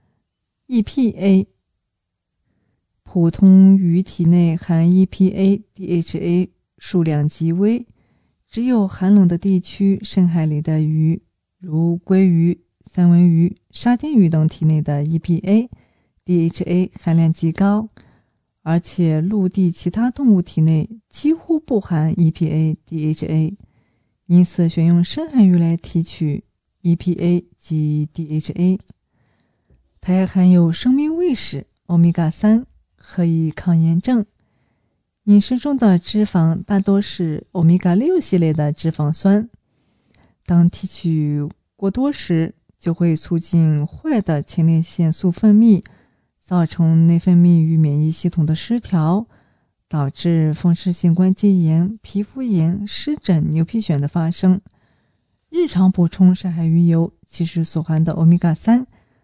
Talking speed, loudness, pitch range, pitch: 195 characters per minute, -17 LUFS, 160-195 Hz, 175 Hz